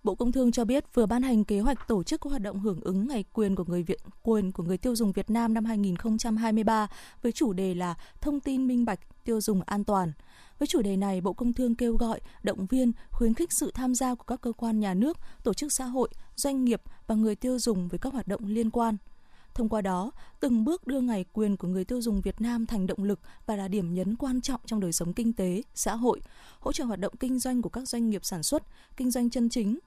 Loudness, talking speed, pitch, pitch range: -29 LUFS, 255 wpm, 225 Hz, 200-250 Hz